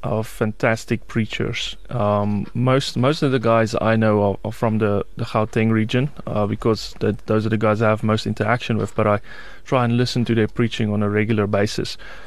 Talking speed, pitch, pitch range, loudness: 205 wpm, 110 Hz, 105-120 Hz, -20 LUFS